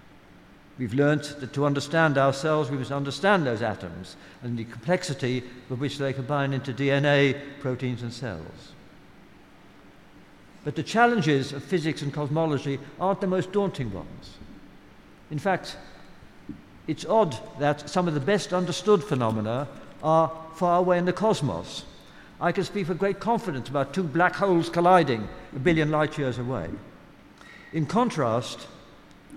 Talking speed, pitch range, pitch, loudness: 145 wpm, 130-175 Hz, 145 Hz, -26 LUFS